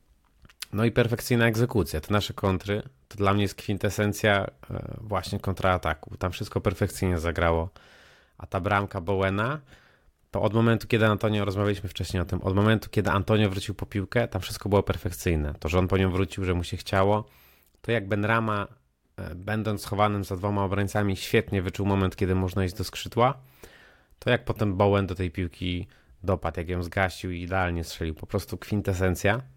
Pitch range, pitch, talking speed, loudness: 90-105 Hz, 100 Hz, 175 wpm, -27 LUFS